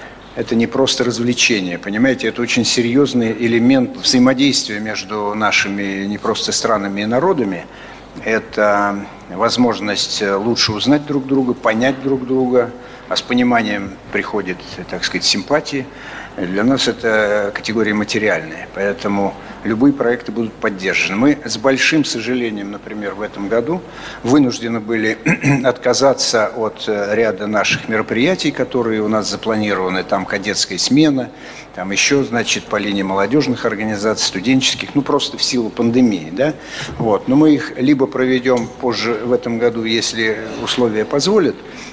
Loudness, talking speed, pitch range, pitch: -16 LUFS, 130 wpm, 105-130 Hz, 120 Hz